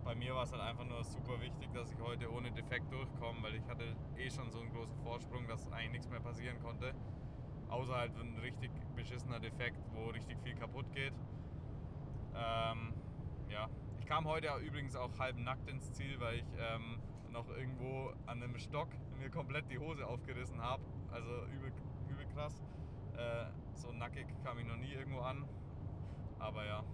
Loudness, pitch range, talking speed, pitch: -45 LUFS, 115-130 Hz, 180 wpm, 120 Hz